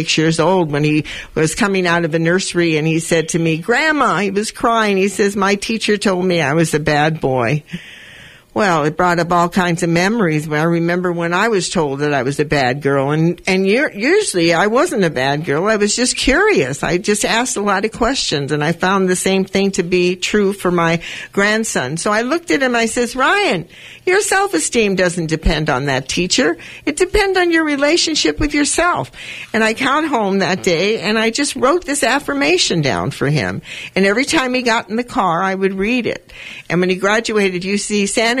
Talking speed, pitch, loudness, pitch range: 220 wpm, 195 Hz, -15 LUFS, 170-235 Hz